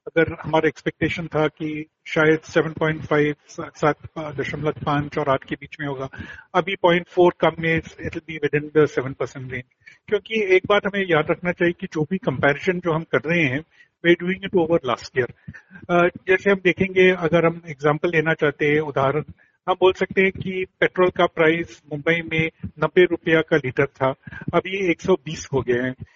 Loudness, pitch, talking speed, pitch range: -21 LUFS, 160 Hz, 180 wpm, 150-175 Hz